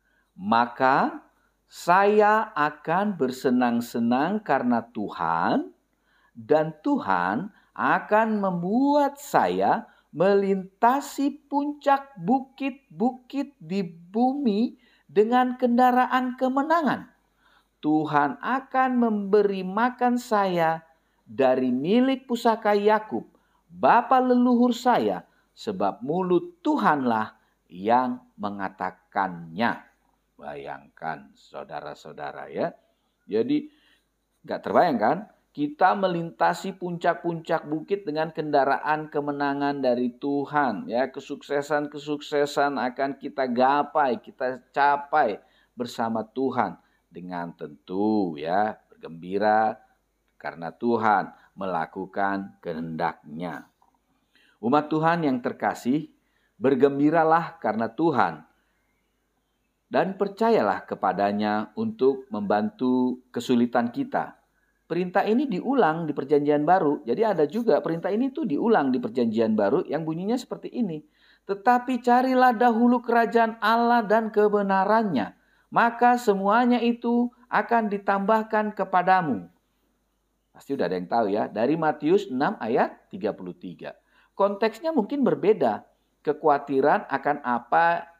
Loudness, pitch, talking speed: -24 LUFS, 175 Hz, 90 wpm